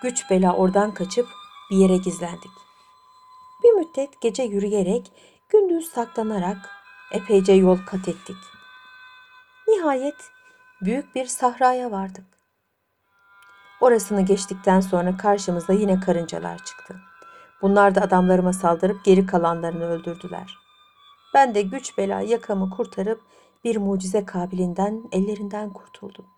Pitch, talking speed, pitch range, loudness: 200 Hz, 105 wpm, 185-250 Hz, -21 LUFS